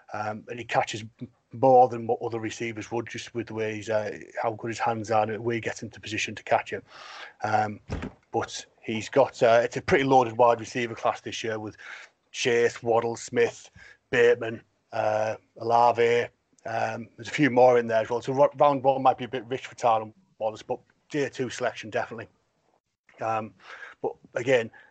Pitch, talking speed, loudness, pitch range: 115 Hz, 190 wpm, -26 LUFS, 110-125 Hz